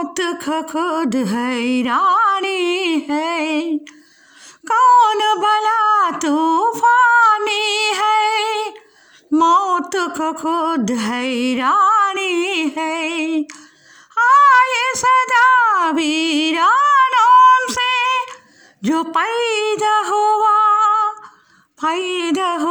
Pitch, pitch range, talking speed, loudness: 380 Hz, 320-430 Hz, 60 wpm, -15 LUFS